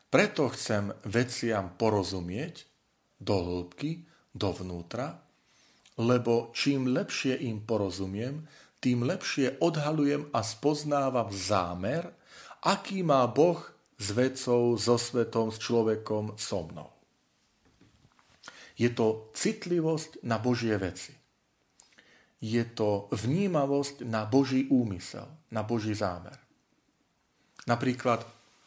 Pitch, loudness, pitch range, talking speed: 120 Hz, -30 LUFS, 105-135 Hz, 95 wpm